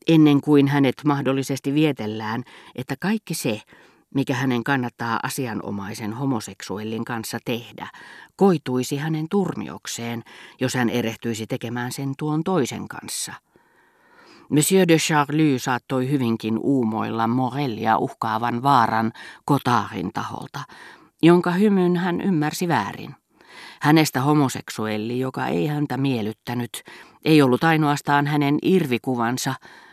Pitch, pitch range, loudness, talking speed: 135 Hz, 115-150 Hz, -22 LUFS, 105 wpm